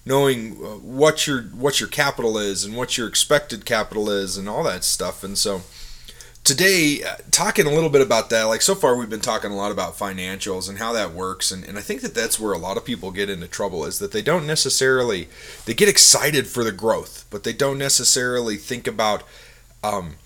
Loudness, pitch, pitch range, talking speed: -20 LUFS, 115 Hz, 100-140 Hz, 215 wpm